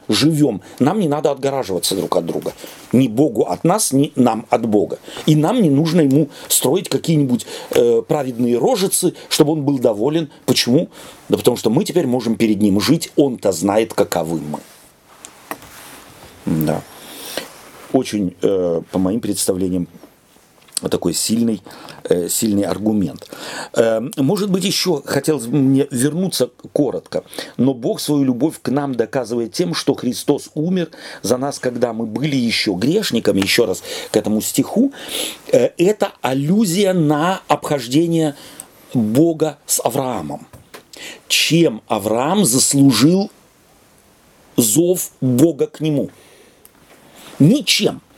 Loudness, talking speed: -17 LUFS, 125 wpm